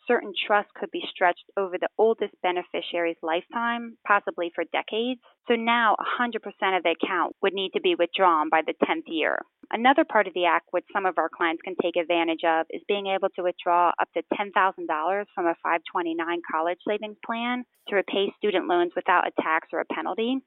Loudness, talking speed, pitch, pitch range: -25 LUFS, 195 wpm, 190 Hz, 170-215 Hz